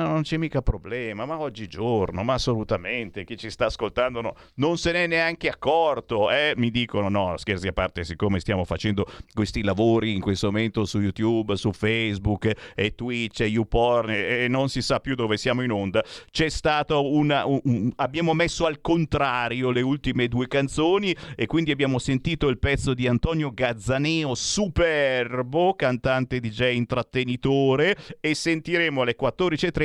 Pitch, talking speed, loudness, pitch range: 125 Hz, 160 wpm, -24 LUFS, 110-150 Hz